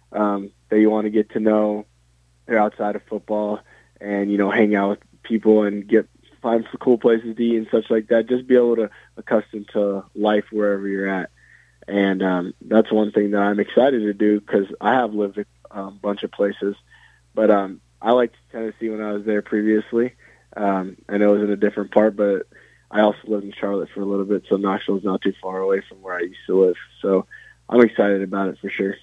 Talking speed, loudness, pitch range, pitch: 225 wpm, -21 LUFS, 100-110 Hz, 105 Hz